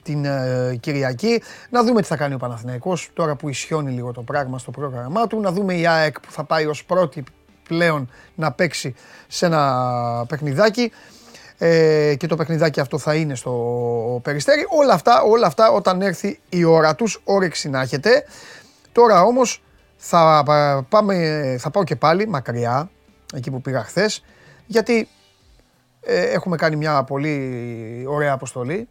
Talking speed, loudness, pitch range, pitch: 155 wpm, -19 LUFS, 135-185 Hz, 155 Hz